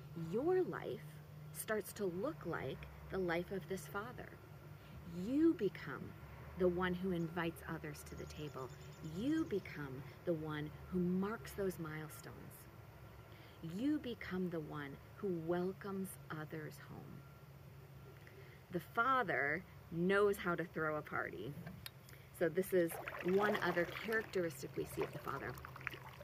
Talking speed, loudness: 130 wpm, -41 LUFS